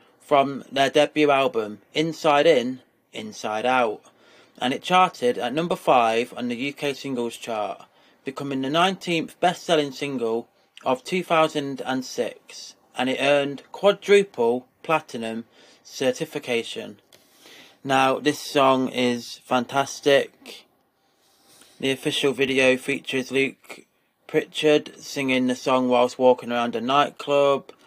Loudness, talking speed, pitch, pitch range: -23 LUFS, 110 wpm, 140 Hz, 125-155 Hz